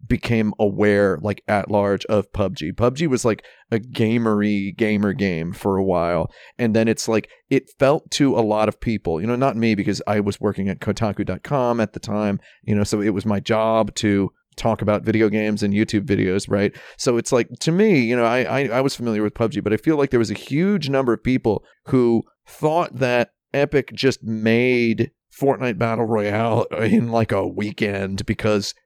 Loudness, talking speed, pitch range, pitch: -20 LUFS, 200 wpm, 105-120 Hz, 110 Hz